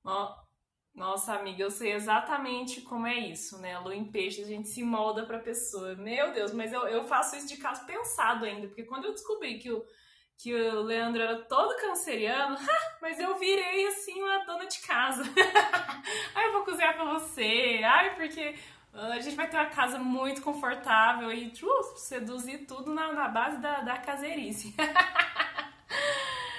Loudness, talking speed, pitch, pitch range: -30 LUFS, 170 wpm, 260 Hz, 225-325 Hz